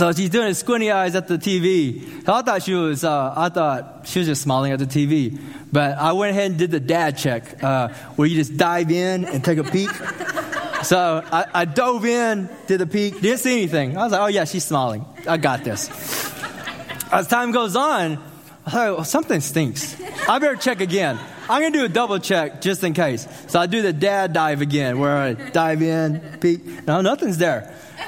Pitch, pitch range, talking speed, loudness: 170 Hz, 150-195 Hz, 215 wpm, -20 LUFS